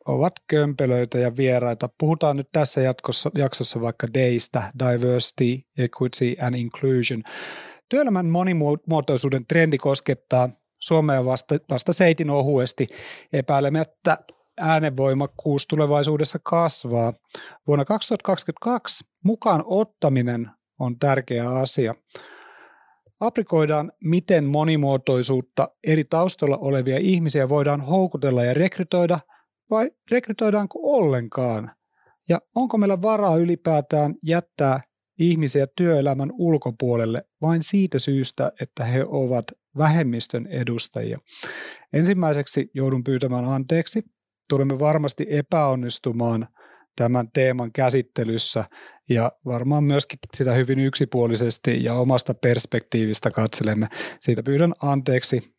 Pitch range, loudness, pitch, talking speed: 125-165 Hz, -22 LUFS, 140 Hz, 95 wpm